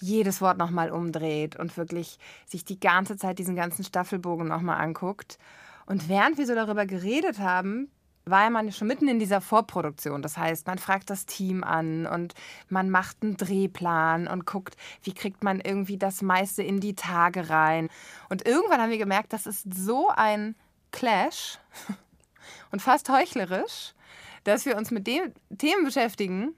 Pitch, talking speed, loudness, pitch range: 195 Hz, 170 wpm, -27 LUFS, 175-215 Hz